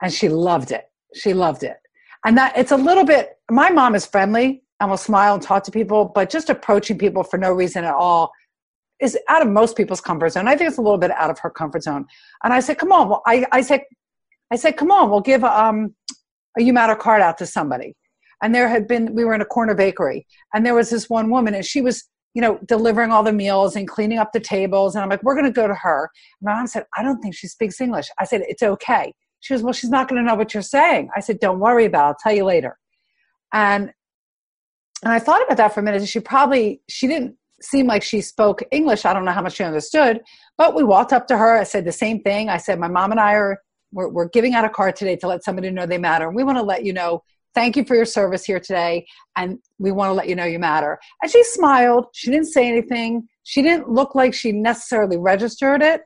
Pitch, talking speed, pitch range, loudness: 220 Hz, 255 wpm, 195-255 Hz, -18 LUFS